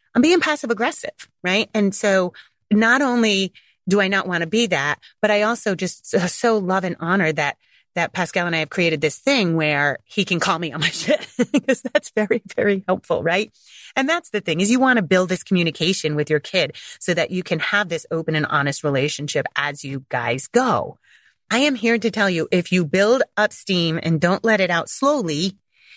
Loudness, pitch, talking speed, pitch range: -20 LUFS, 190 Hz, 215 wpm, 165-225 Hz